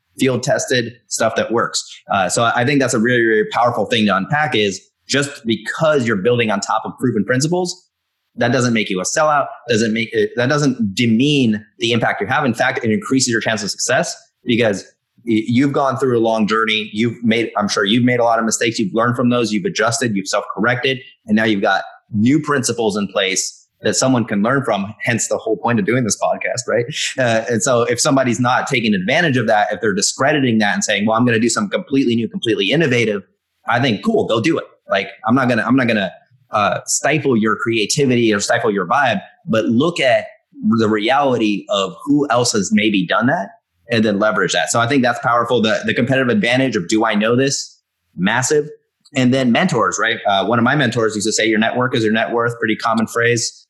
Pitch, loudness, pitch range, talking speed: 120 Hz, -16 LUFS, 110-135 Hz, 220 wpm